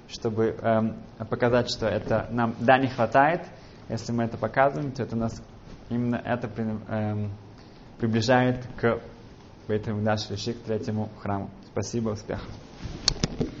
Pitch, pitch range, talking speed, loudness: 115 Hz, 110-120 Hz, 120 wpm, -27 LUFS